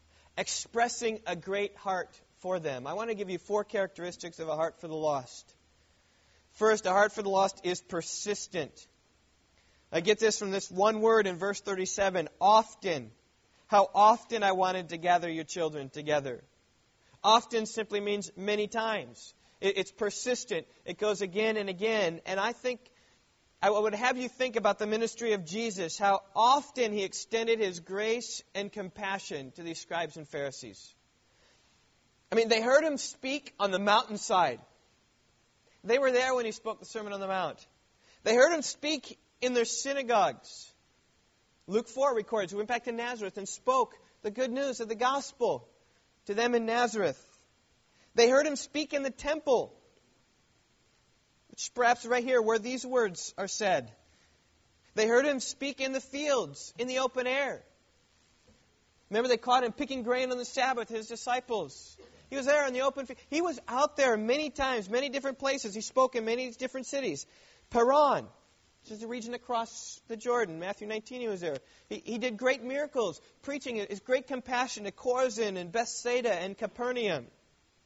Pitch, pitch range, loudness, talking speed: 220 Hz, 195-250 Hz, -30 LUFS, 170 wpm